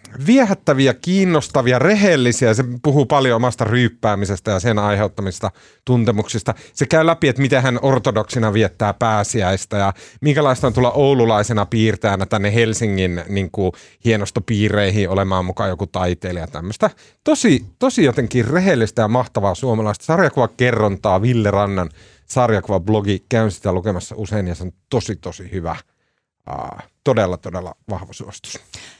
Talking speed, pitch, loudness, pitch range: 135 wpm, 110 Hz, -17 LUFS, 100-125 Hz